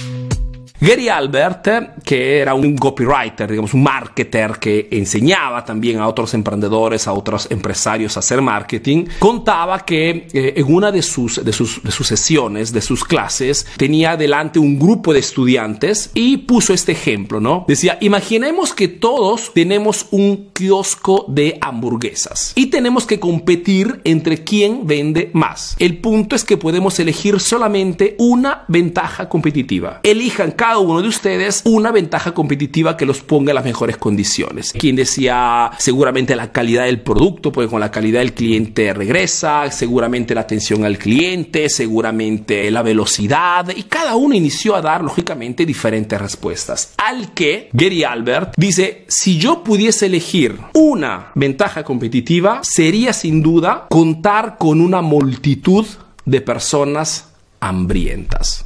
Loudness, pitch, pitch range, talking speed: -15 LUFS, 155 Hz, 120-195 Hz, 145 wpm